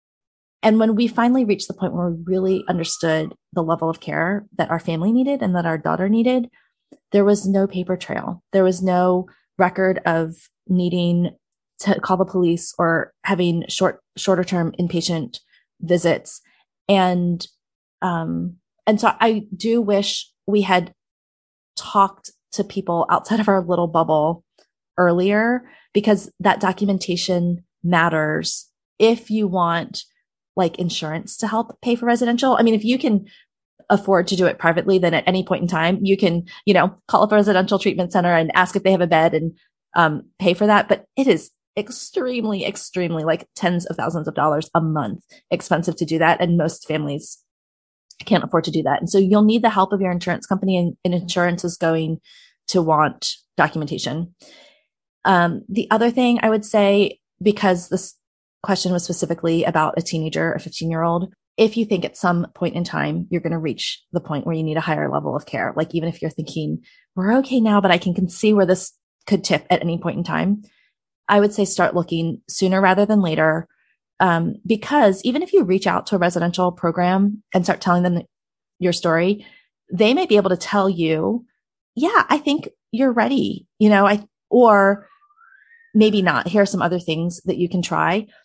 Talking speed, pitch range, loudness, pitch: 185 wpm, 170-205 Hz, -19 LUFS, 185 Hz